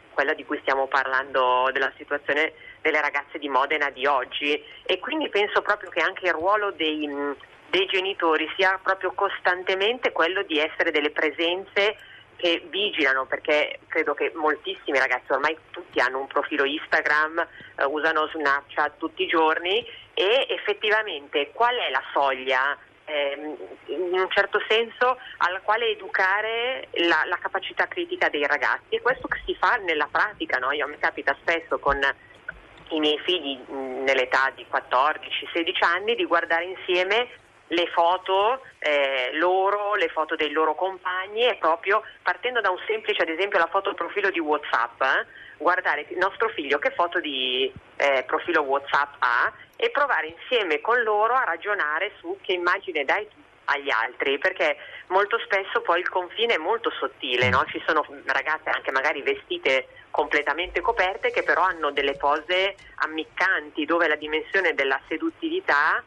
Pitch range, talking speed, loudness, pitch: 150-220 Hz, 155 wpm, -24 LUFS, 180 Hz